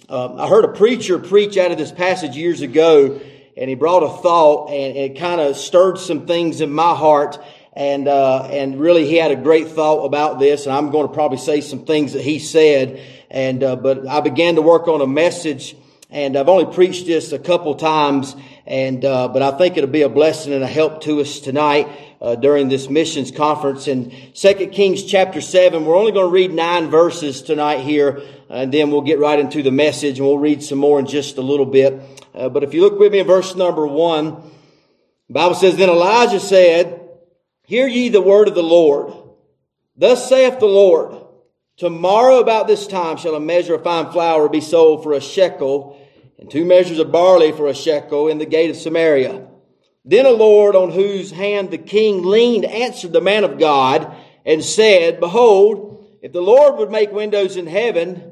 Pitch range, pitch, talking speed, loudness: 145-185 Hz, 155 Hz, 205 wpm, -15 LUFS